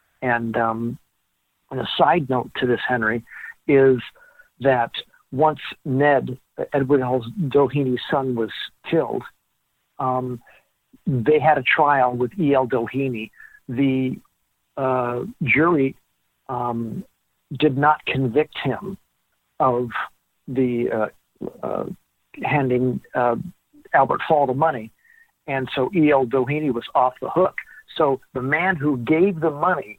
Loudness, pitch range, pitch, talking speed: -21 LUFS, 125-150 Hz, 130 Hz, 120 wpm